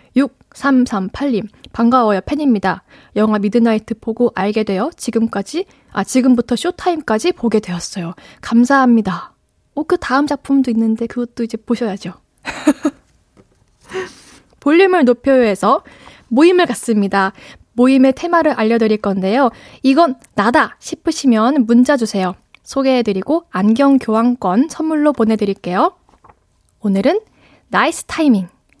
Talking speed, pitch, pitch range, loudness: 285 characters per minute, 245 Hz, 215-285 Hz, -15 LUFS